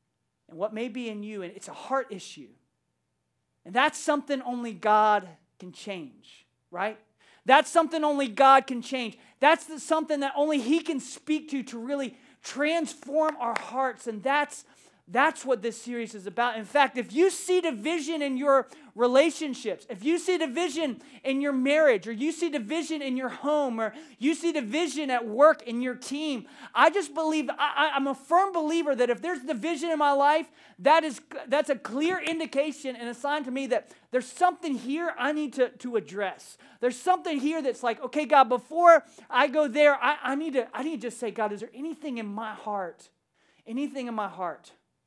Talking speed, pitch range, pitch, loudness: 195 wpm, 235-305 Hz, 275 Hz, -26 LUFS